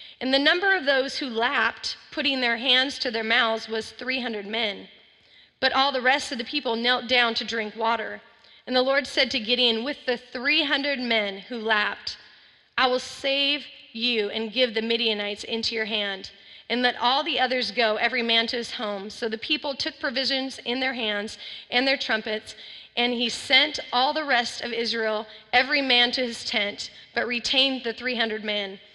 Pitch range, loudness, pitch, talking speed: 225-265 Hz, -24 LUFS, 245 Hz, 190 wpm